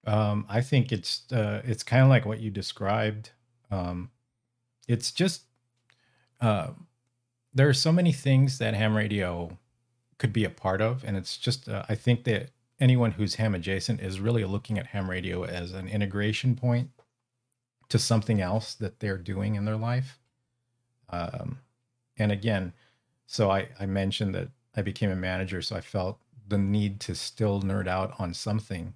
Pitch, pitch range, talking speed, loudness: 110 Hz, 100-125 Hz, 170 wpm, -28 LUFS